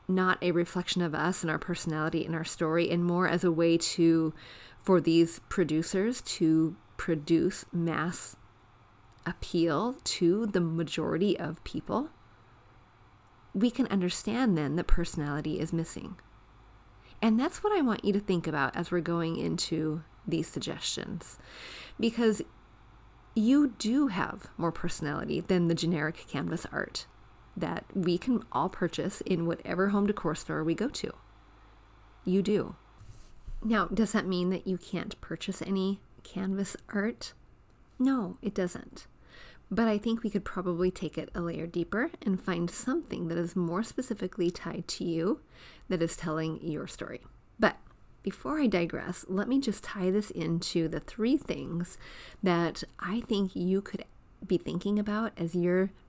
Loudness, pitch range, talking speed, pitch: -31 LUFS, 160-200 Hz, 150 wpm, 175 Hz